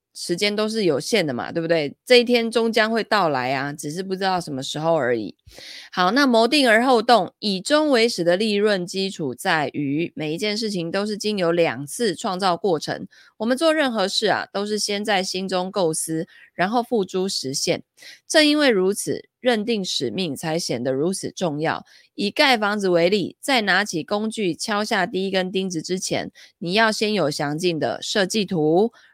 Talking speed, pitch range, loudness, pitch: 270 characters per minute, 170-220 Hz, -21 LUFS, 190 Hz